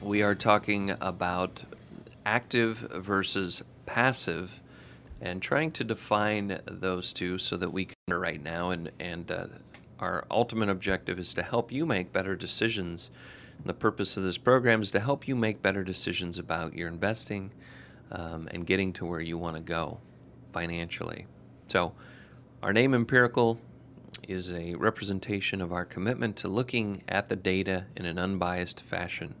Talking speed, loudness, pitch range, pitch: 155 wpm, -30 LUFS, 90-110 Hz, 95 Hz